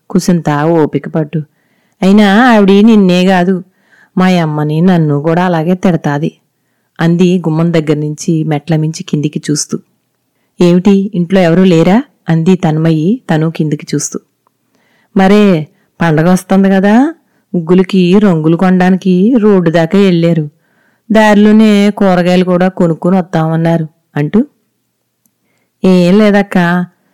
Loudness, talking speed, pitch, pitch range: -9 LUFS, 100 wpm, 180 Hz, 165-195 Hz